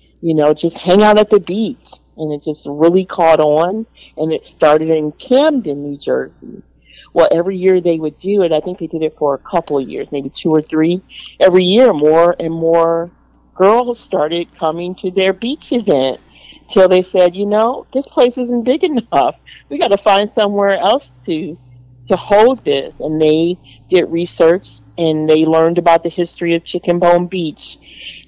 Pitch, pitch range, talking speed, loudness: 170 Hz, 155-195 Hz, 190 wpm, -14 LUFS